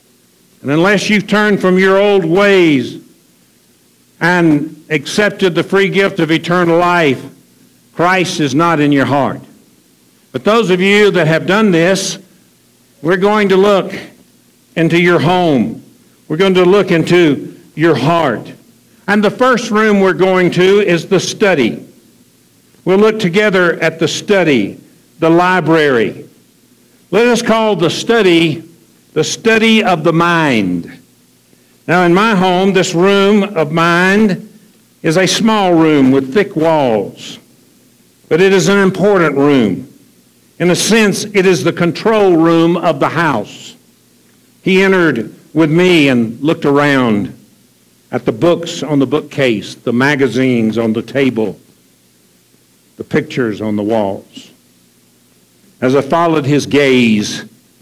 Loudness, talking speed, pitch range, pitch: -12 LUFS, 135 wpm, 145-190 Hz, 170 Hz